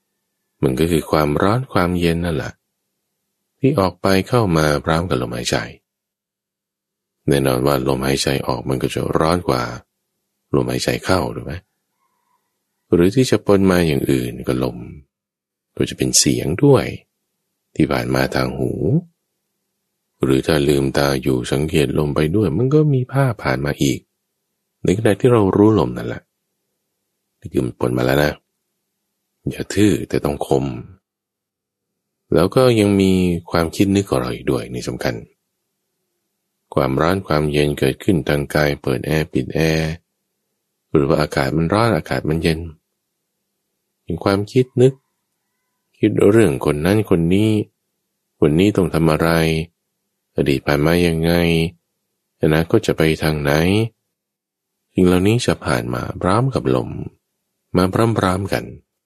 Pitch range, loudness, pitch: 70-105 Hz, -18 LUFS, 80 Hz